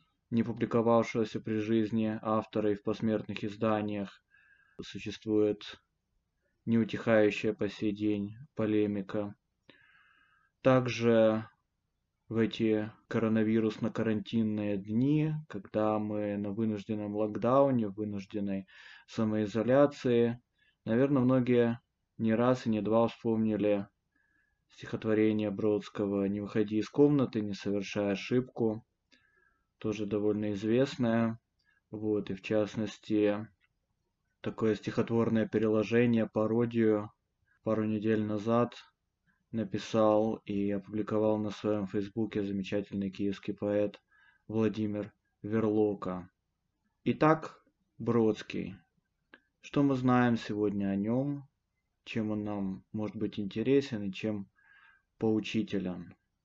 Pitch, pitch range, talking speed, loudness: 110 Hz, 105-115 Hz, 90 wpm, -31 LUFS